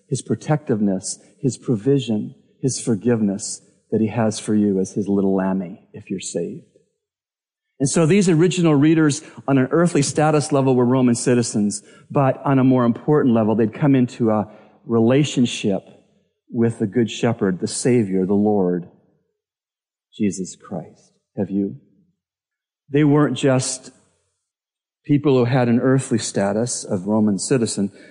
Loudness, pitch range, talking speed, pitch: -19 LUFS, 105-140 Hz, 140 wpm, 120 Hz